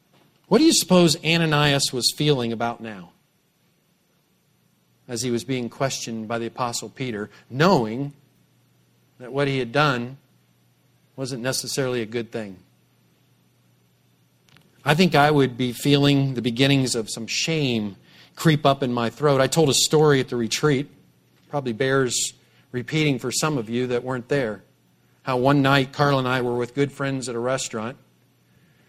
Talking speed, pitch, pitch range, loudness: 155 wpm, 130 Hz, 120-145 Hz, -22 LUFS